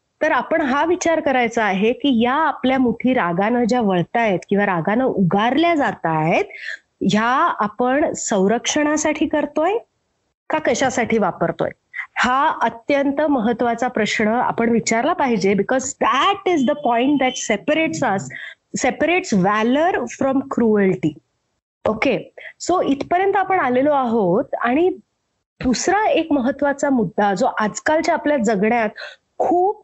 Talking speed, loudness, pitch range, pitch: 120 wpm, -18 LUFS, 220-300 Hz, 255 Hz